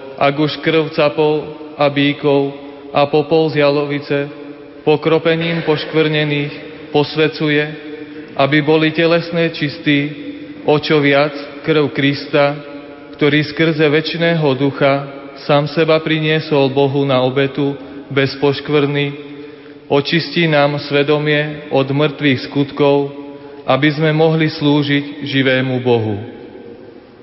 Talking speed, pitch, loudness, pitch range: 100 wpm, 145 Hz, -15 LUFS, 140-155 Hz